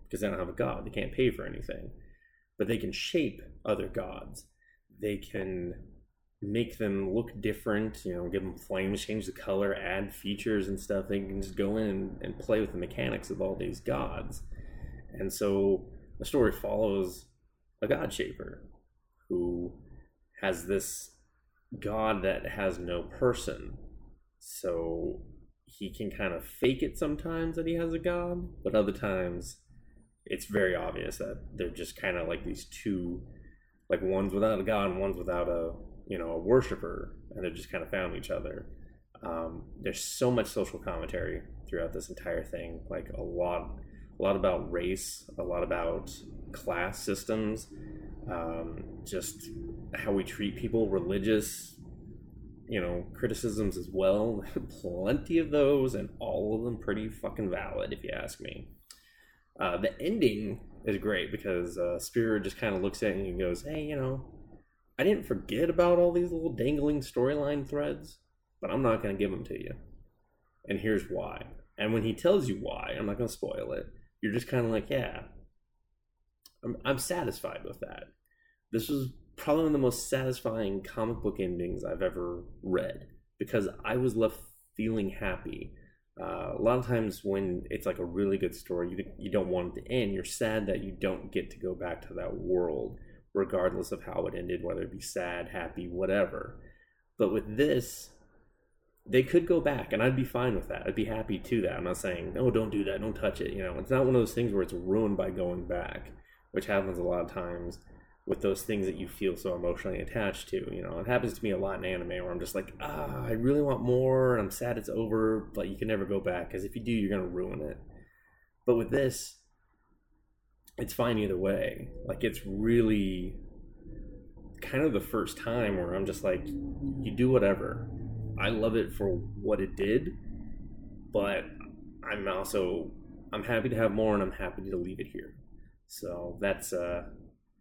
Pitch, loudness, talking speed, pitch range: 105 Hz, -32 LUFS, 185 wpm, 95-120 Hz